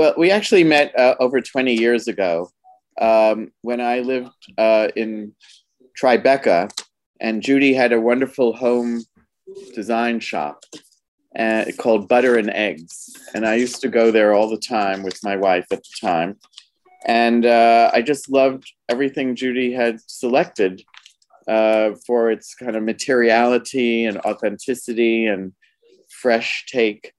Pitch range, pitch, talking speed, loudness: 110-130 Hz, 120 Hz, 140 wpm, -18 LUFS